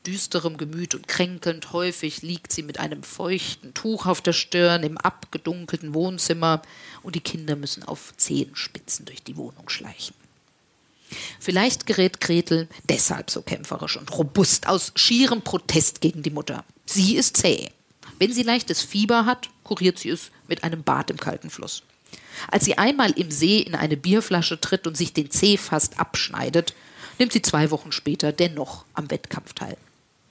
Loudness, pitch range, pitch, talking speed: -21 LUFS, 155-190 Hz, 170 Hz, 160 wpm